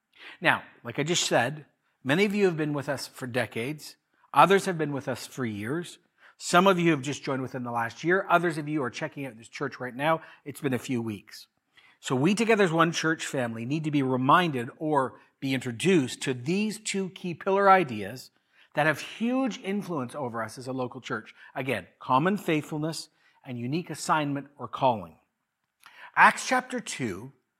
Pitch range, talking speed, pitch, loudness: 130-175 Hz, 190 wpm, 150 Hz, -27 LUFS